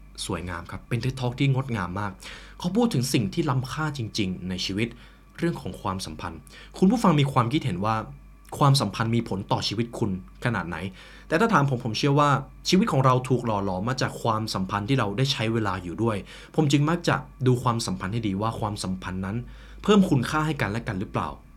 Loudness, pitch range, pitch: -25 LUFS, 100-140 Hz, 115 Hz